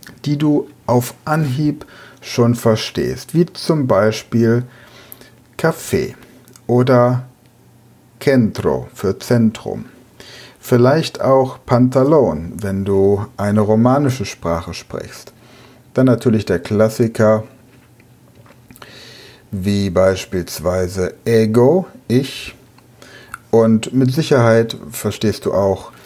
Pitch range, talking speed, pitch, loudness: 110-130 Hz, 85 wpm, 120 Hz, -16 LUFS